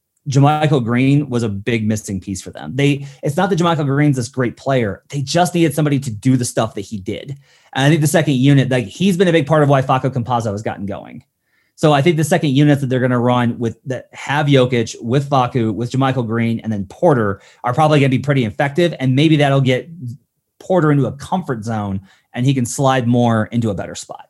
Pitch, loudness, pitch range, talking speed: 130 Hz, -16 LUFS, 120-145 Hz, 235 wpm